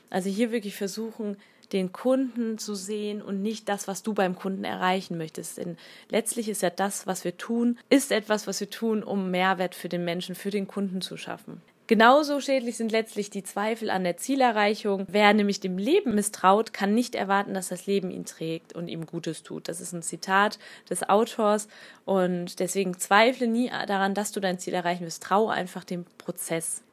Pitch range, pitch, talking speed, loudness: 185-220 Hz, 200 Hz, 195 wpm, -27 LUFS